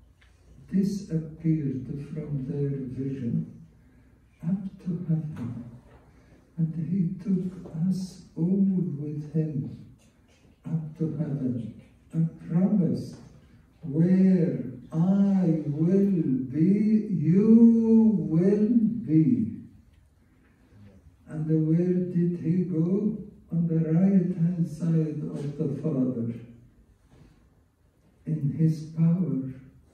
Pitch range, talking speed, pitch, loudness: 135-180 Hz, 85 wpm, 160 Hz, -26 LUFS